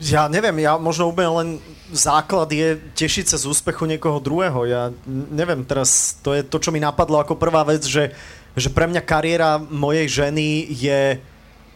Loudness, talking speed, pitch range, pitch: -19 LUFS, 175 wpm, 140-165 Hz, 155 Hz